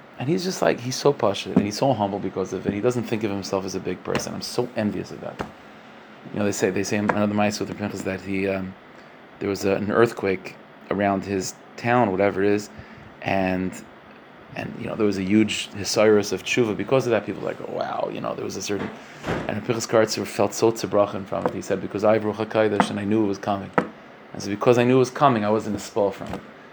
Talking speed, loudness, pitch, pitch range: 245 wpm, -23 LUFS, 105 Hz, 95-115 Hz